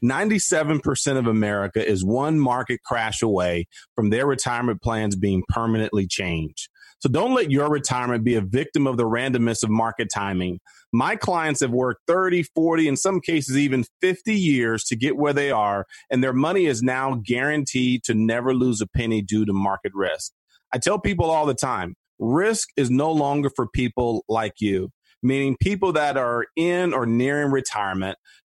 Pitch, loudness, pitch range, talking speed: 125 Hz, -22 LUFS, 110-145 Hz, 175 wpm